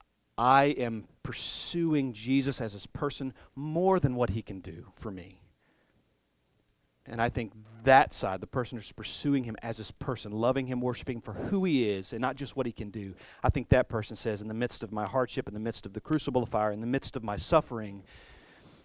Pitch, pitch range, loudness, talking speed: 115 Hz, 105-130 Hz, -30 LUFS, 215 wpm